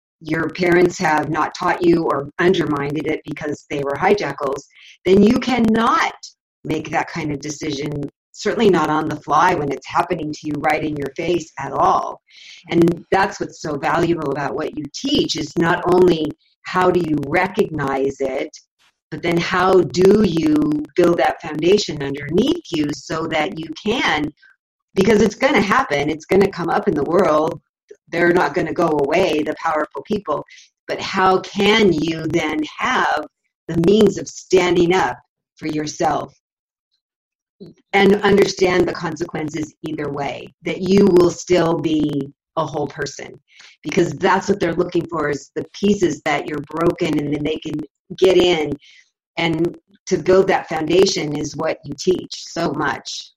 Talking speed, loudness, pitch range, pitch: 165 wpm, -18 LUFS, 155-185 Hz, 170 Hz